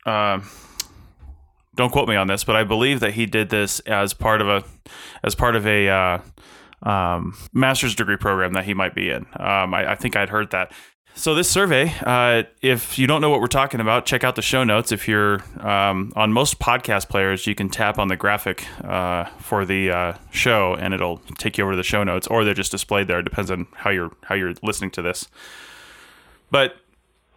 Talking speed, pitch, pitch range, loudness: 215 wpm, 100 Hz, 95-115 Hz, -20 LUFS